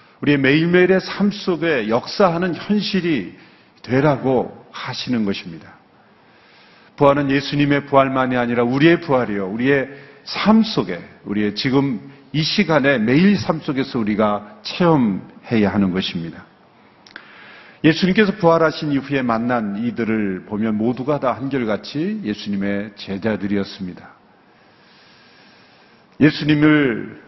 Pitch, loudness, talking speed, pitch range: 140 Hz, -18 LUFS, 275 characters per minute, 110-160 Hz